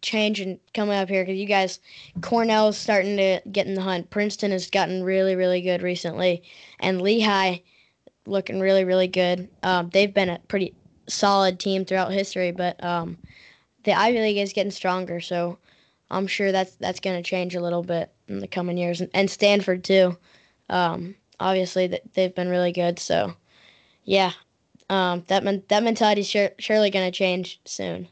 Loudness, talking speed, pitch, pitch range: -23 LUFS, 180 wpm, 190 Hz, 180-200 Hz